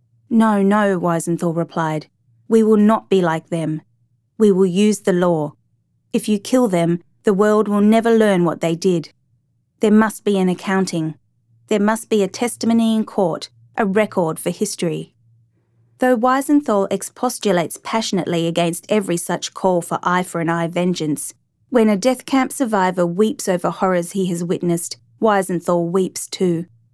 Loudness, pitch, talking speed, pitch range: -18 LUFS, 185 Hz, 160 wpm, 165-215 Hz